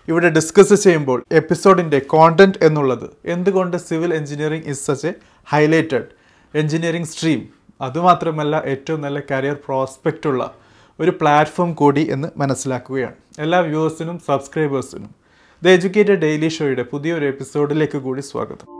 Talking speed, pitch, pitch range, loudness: 120 wpm, 155 Hz, 140-170 Hz, -17 LUFS